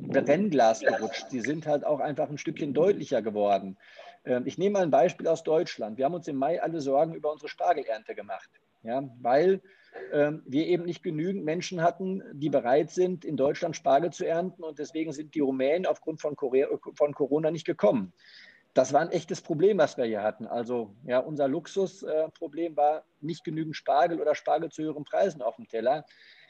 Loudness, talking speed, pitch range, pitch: -28 LUFS, 180 wpm, 145-175 Hz, 155 Hz